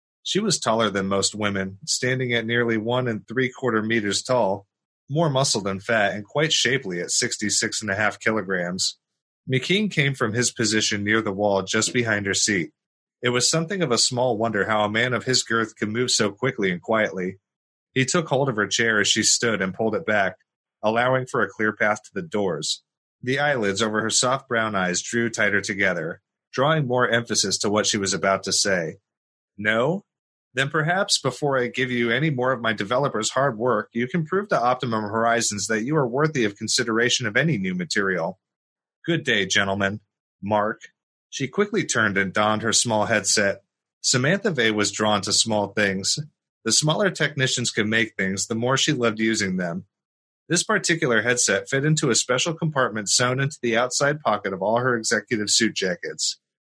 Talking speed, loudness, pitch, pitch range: 190 wpm, -22 LUFS, 115 Hz, 105-130 Hz